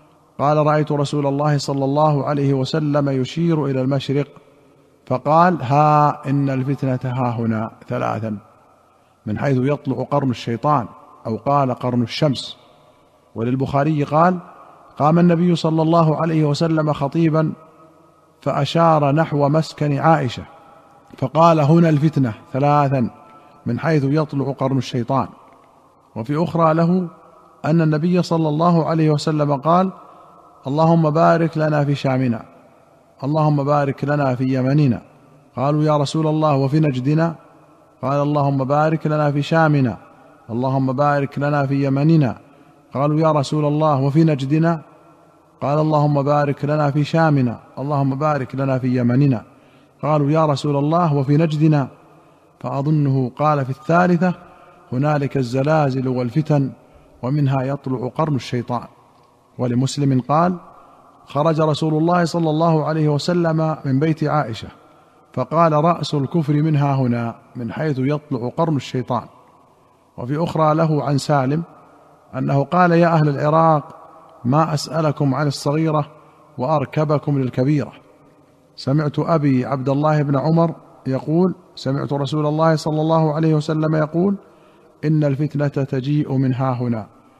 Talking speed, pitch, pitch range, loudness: 120 wpm, 145 Hz, 135-155 Hz, -18 LUFS